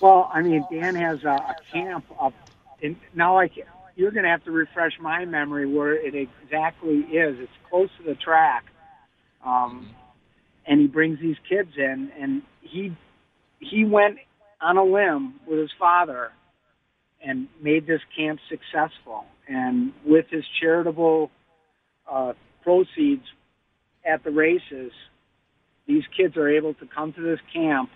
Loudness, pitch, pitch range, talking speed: -23 LUFS, 160 Hz, 150-185 Hz, 150 wpm